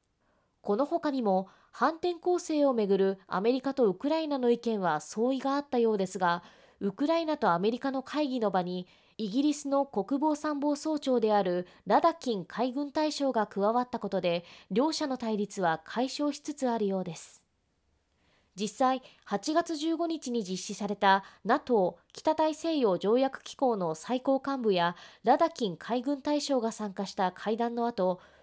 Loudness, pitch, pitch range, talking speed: -30 LUFS, 235 Hz, 195-285 Hz, 310 characters per minute